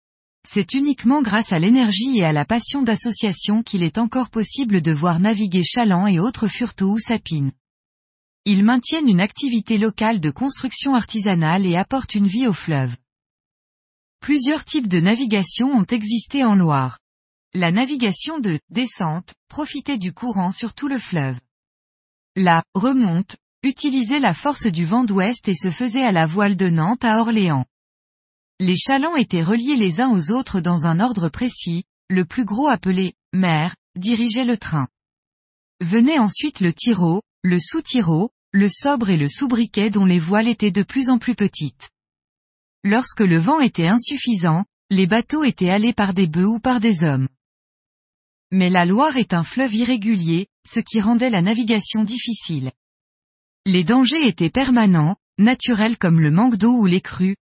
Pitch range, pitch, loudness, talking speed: 175-240 Hz, 210 Hz, -19 LUFS, 160 wpm